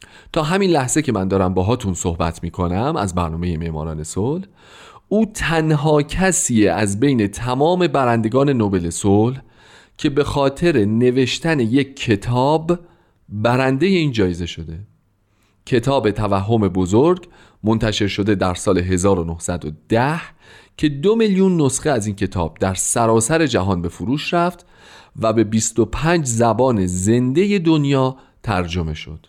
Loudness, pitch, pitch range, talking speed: -18 LUFS, 115 Hz, 95-150 Hz, 125 wpm